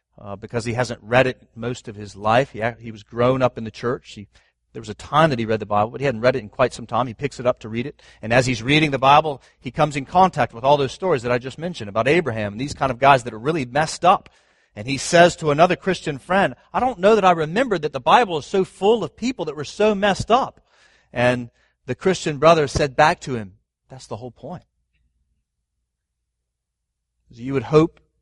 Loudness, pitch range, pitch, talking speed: -20 LUFS, 110-155 Hz, 125 Hz, 245 wpm